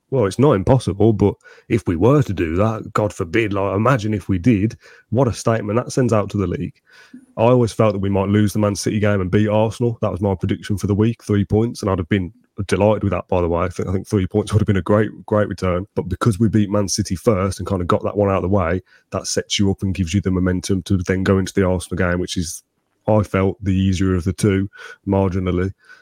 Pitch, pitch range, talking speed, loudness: 100 Hz, 95-110 Hz, 270 wpm, -19 LUFS